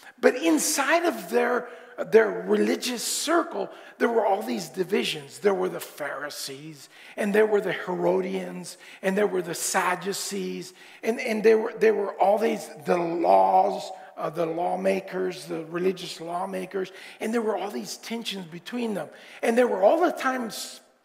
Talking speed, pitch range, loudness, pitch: 160 wpm, 180-235 Hz, -25 LUFS, 190 Hz